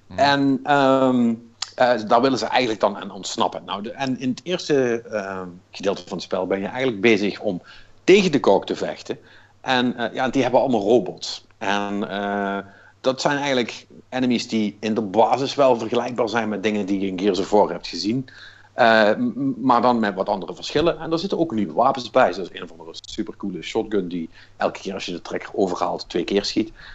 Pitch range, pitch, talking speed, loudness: 100-130 Hz, 115 Hz, 210 wpm, -21 LUFS